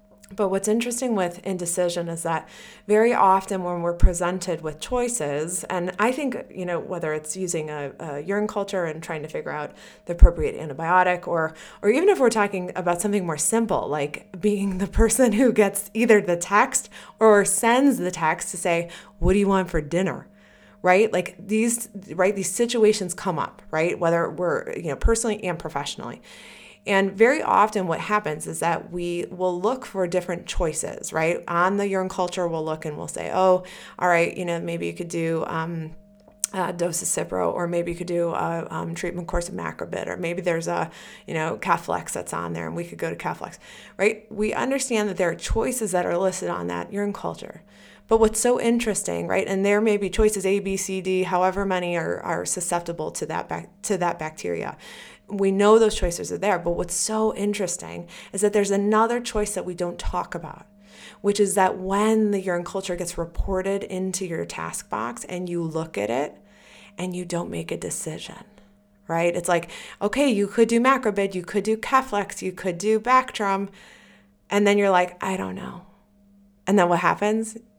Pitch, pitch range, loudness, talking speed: 185 Hz, 170-210 Hz, -24 LUFS, 195 wpm